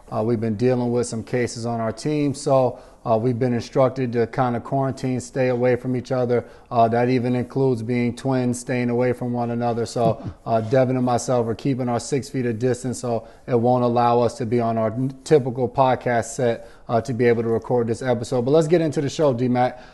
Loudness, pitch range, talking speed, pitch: -22 LUFS, 120-130 Hz, 225 wpm, 125 Hz